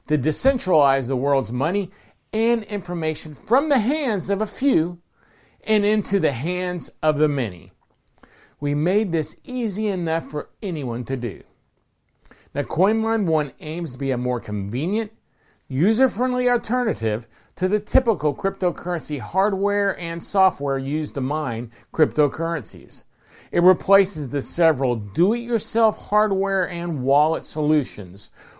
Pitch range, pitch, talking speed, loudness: 140-205 Hz, 170 Hz, 125 wpm, -22 LUFS